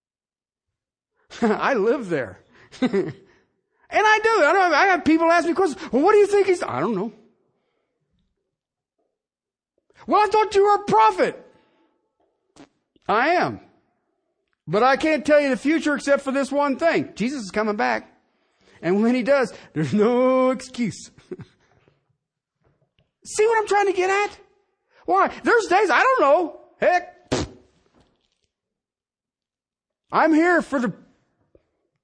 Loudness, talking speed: -20 LUFS, 140 wpm